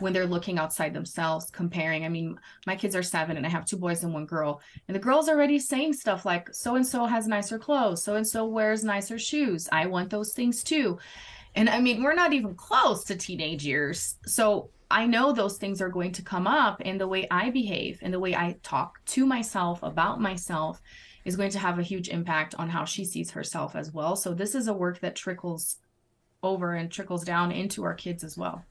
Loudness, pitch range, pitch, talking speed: -28 LUFS, 170-215 Hz, 190 Hz, 220 wpm